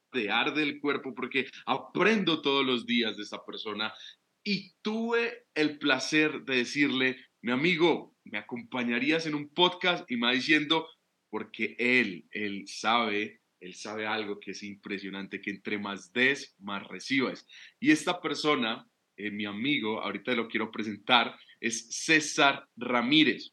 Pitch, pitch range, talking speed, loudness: 125 Hz, 110-155 Hz, 150 wpm, -29 LUFS